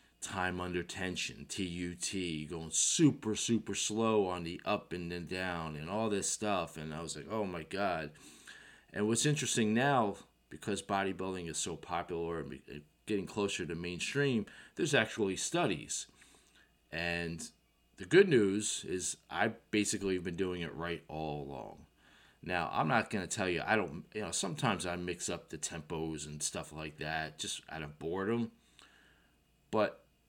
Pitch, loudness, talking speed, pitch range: 90 Hz, -35 LUFS, 165 wpm, 80-100 Hz